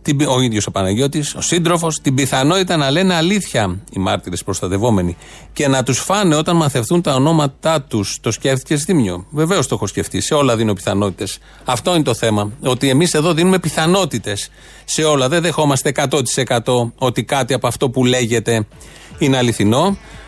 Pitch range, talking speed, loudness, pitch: 110-155 Hz, 165 wpm, -16 LUFS, 130 Hz